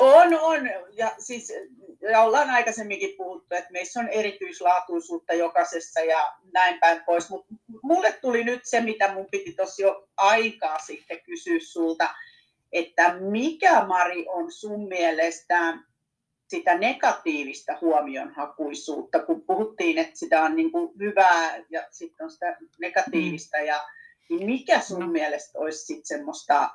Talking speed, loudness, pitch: 135 wpm, -24 LUFS, 195 Hz